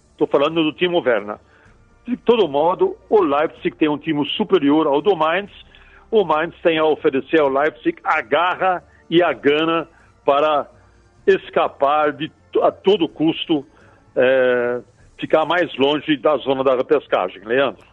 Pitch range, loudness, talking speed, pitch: 150-245 Hz, -18 LUFS, 145 wpm, 165 Hz